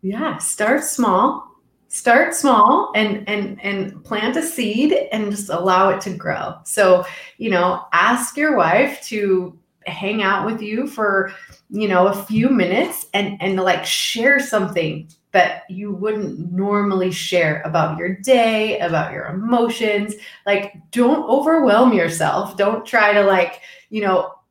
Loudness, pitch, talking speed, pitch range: -18 LUFS, 205 Hz, 145 wpm, 185-230 Hz